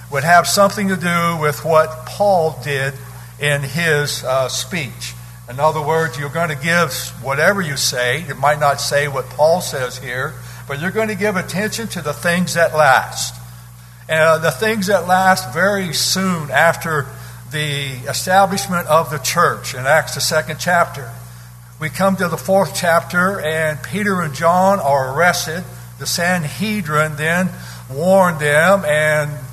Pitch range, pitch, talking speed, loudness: 135-175 Hz, 155 Hz, 160 wpm, -16 LUFS